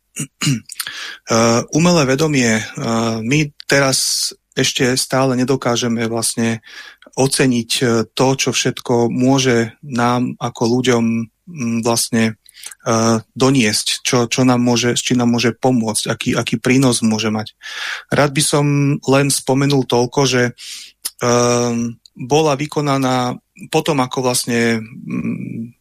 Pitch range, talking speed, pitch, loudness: 115-135 Hz, 100 wpm, 125 Hz, -16 LUFS